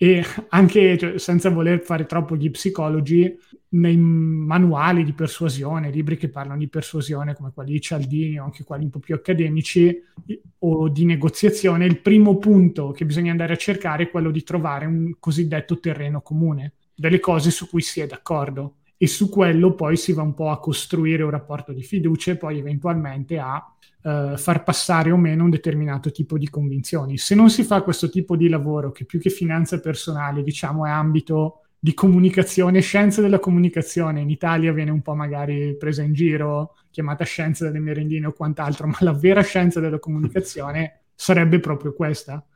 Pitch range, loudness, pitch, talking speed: 150-175 Hz, -20 LUFS, 160 Hz, 180 wpm